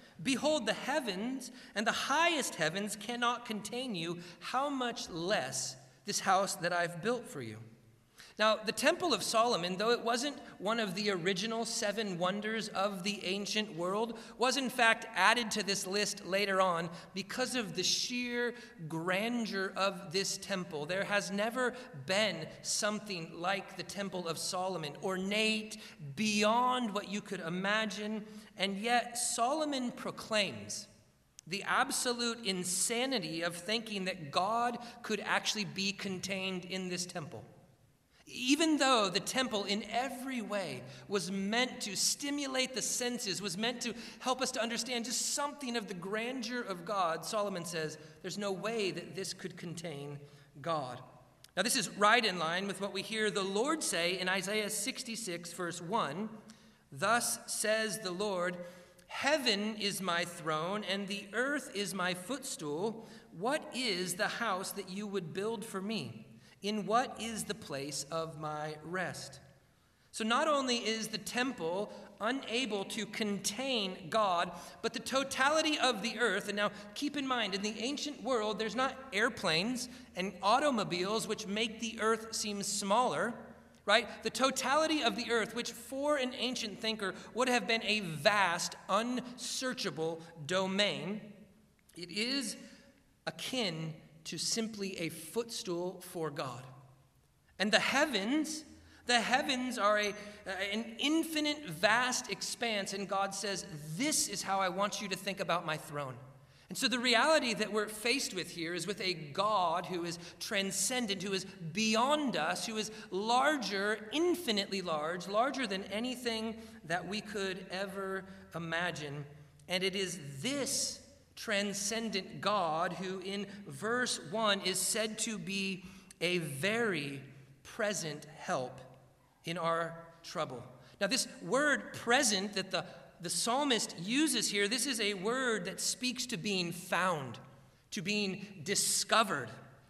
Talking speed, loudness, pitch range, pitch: 145 wpm, -34 LUFS, 180-235 Hz, 205 Hz